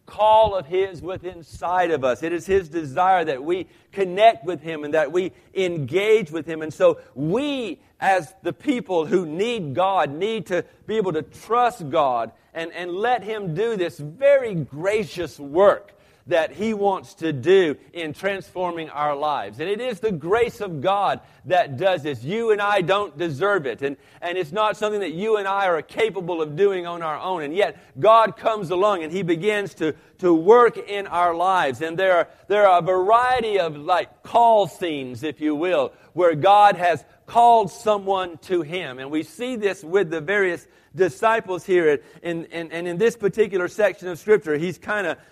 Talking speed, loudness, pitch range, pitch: 190 wpm, -21 LUFS, 165-210 Hz, 185 Hz